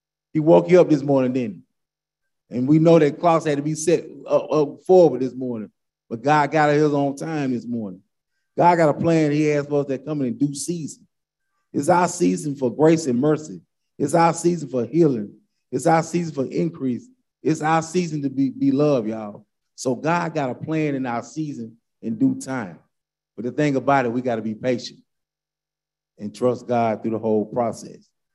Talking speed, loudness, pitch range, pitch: 195 wpm, -21 LUFS, 125-155 Hz, 145 Hz